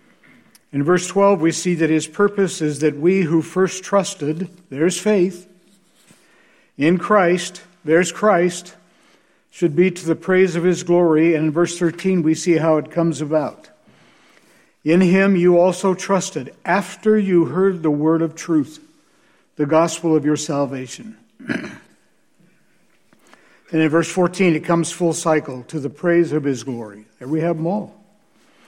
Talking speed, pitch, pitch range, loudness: 155 wpm, 170 Hz, 160-185 Hz, -18 LUFS